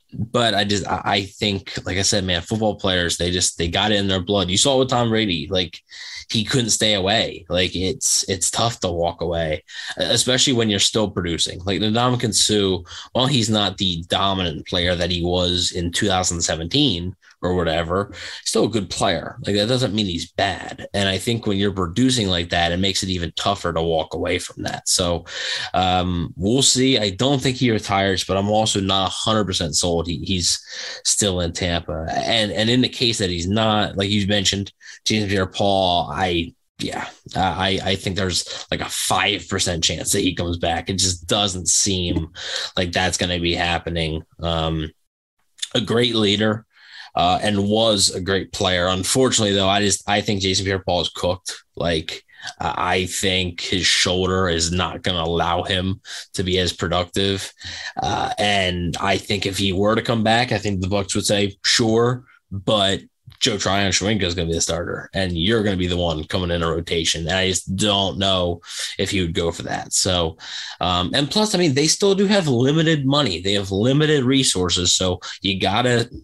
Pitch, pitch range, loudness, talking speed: 95 Hz, 90-105 Hz, -20 LUFS, 195 wpm